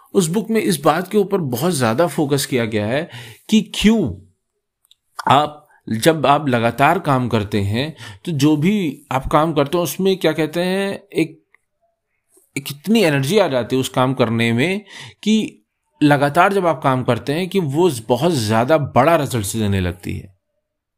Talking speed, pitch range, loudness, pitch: 170 wpm, 120-180 Hz, -18 LUFS, 145 Hz